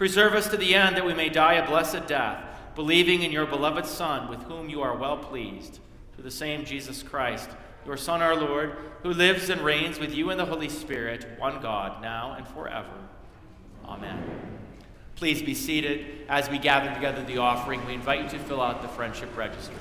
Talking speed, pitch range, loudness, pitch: 200 wpm, 135-165 Hz, -26 LUFS, 150 Hz